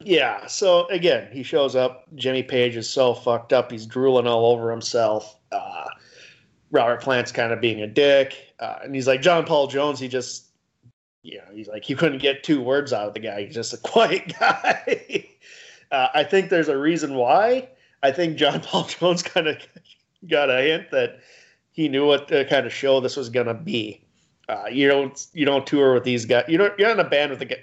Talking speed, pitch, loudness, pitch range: 215 wpm, 135 Hz, -21 LUFS, 125-165 Hz